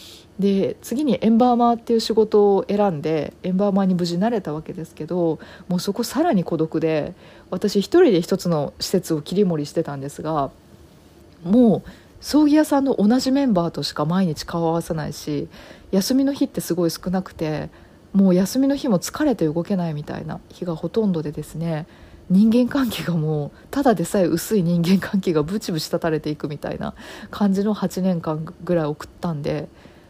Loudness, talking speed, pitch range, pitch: -21 LUFS, 365 characters per minute, 165-215 Hz, 180 Hz